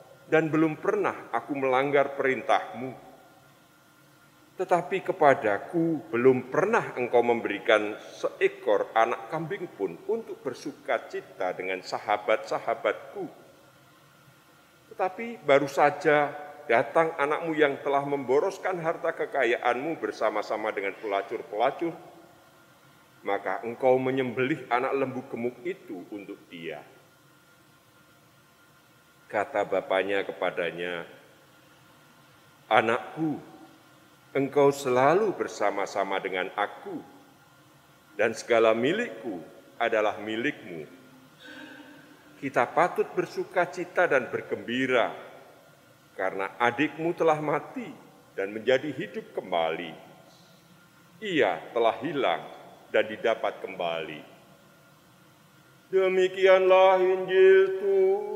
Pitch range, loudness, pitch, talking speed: 135-180 Hz, -27 LUFS, 160 Hz, 80 wpm